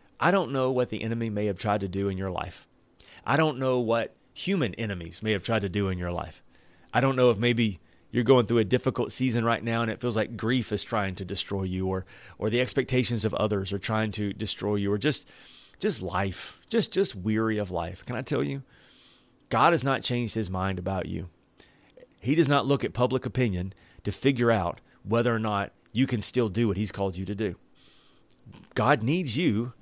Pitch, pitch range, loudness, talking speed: 110 Hz, 100-125 Hz, -27 LUFS, 220 wpm